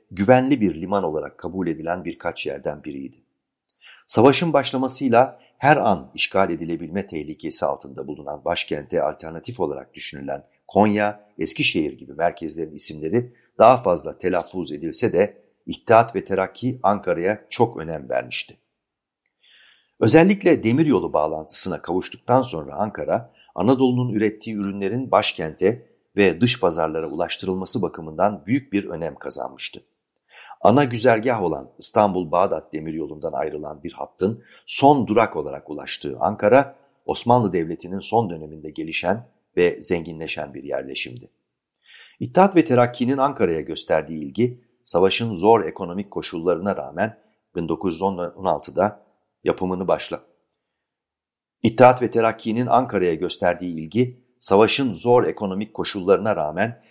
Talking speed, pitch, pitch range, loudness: 110 wpm, 100 Hz, 85-120 Hz, -21 LUFS